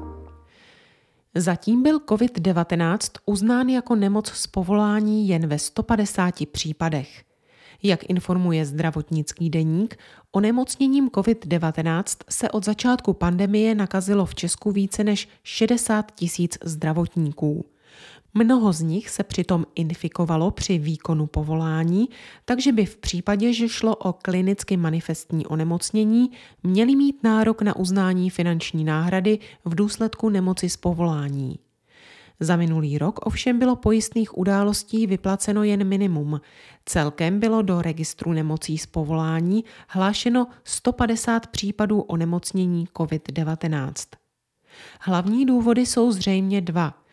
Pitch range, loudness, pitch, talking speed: 165-215 Hz, -22 LUFS, 190 Hz, 115 wpm